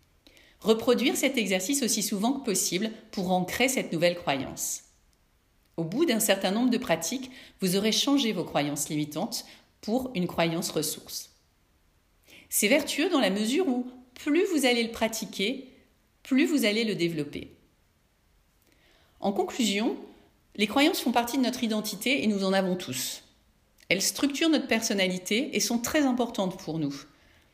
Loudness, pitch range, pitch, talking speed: -27 LUFS, 175-255 Hz, 215 Hz, 150 wpm